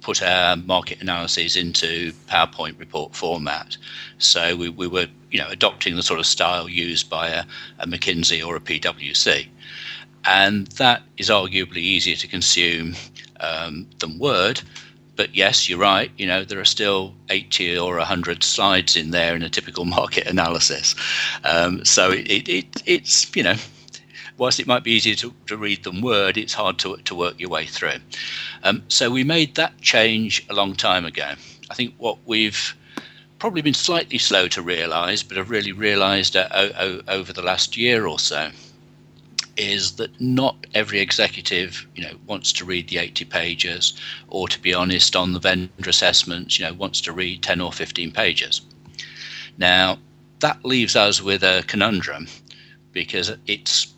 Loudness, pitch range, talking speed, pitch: -19 LUFS, 85-105 Hz, 170 wpm, 95 Hz